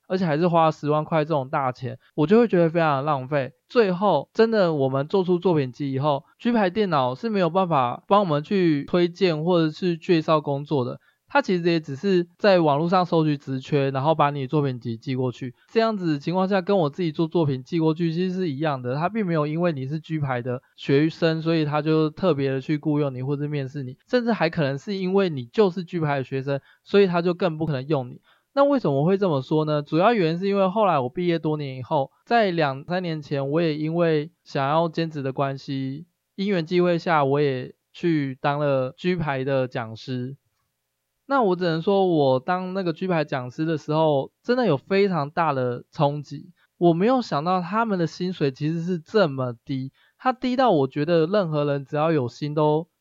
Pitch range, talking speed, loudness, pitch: 140-180 Hz, 305 characters per minute, -23 LUFS, 160 Hz